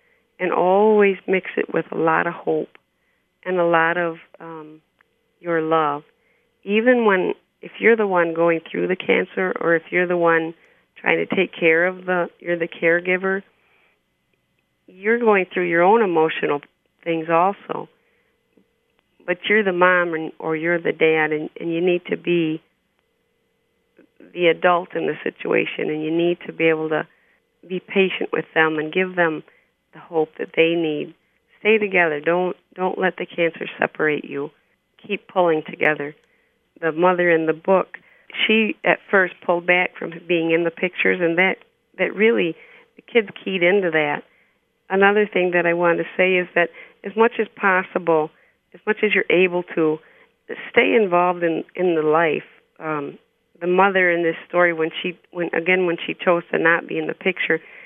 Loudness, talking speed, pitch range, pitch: -20 LUFS, 175 wpm, 165-190 Hz, 175 Hz